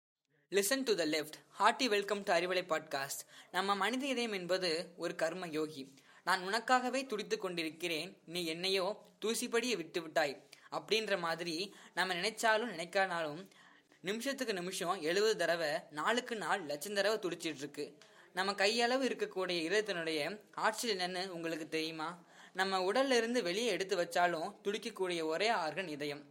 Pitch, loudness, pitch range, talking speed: 185 Hz, -35 LUFS, 165-215 Hz, 125 wpm